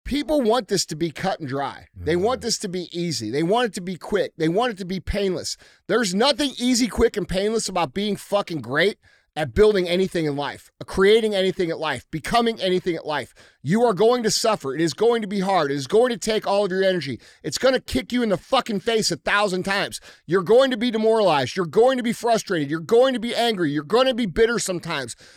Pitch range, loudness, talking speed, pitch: 170-230 Hz, -22 LUFS, 240 wpm, 195 Hz